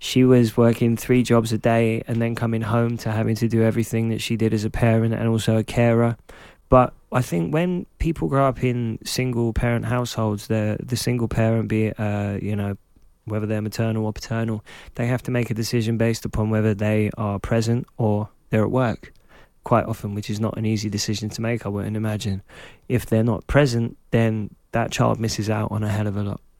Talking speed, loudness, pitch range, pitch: 215 wpm, -22 LUFS, 110-120 Hz, 115 Hz